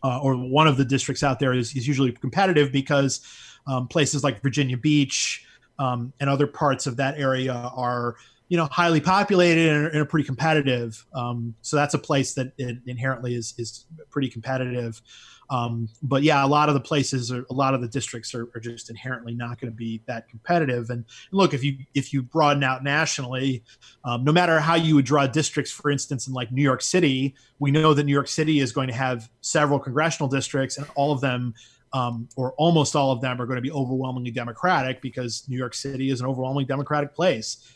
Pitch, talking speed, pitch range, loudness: 135 Hz, 215 wpm, 125-145 Hz, -23 LUFS